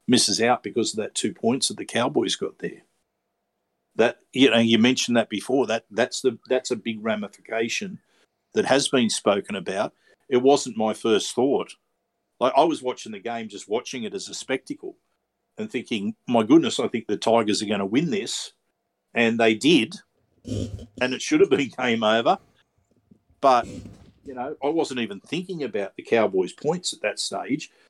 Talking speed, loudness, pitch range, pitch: 185 wpm, -23 LUFS, 115-190 Hz, 125 Hz